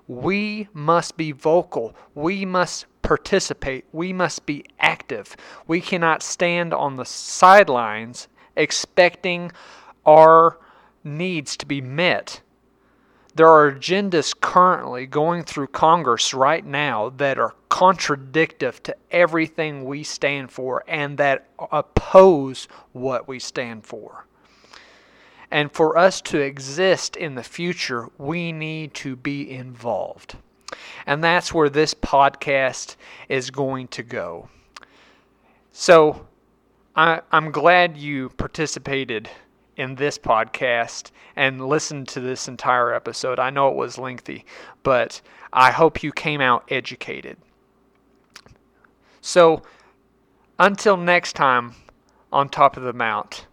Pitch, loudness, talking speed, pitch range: 150 Hz, -19 LUFS, 120 wpm, 135-170 Hz